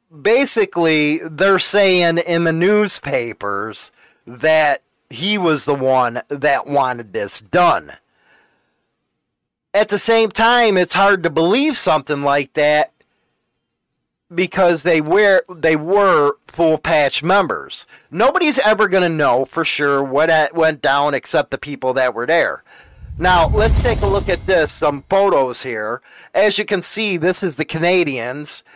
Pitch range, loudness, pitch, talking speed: 145-195 Hz, -16 LUFS, 165 Hz, 145 wpm